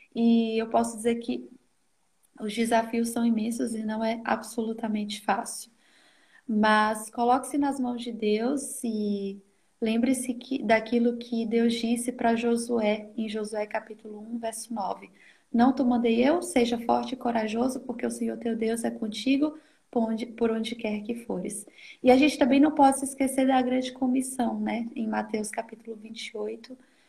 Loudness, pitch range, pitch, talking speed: -27 LUFS, 220-255 Hz, 235 Hz, 160 wpm